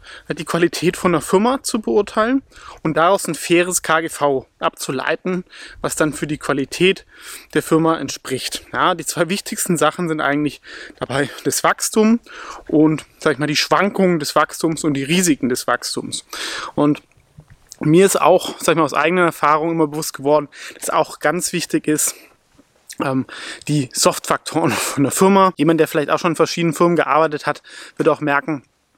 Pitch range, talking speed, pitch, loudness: 150-180 Hz, 165 wpm, 160 Hz, -18 LUFS